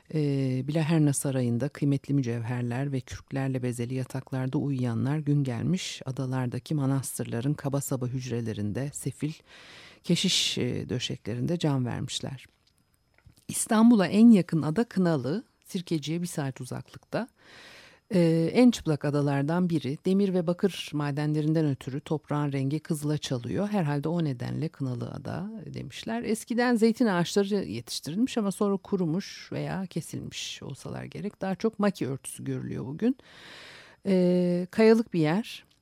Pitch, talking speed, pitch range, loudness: 150 Hz, 120 wpm, 135-185 Hz, -28 LUFS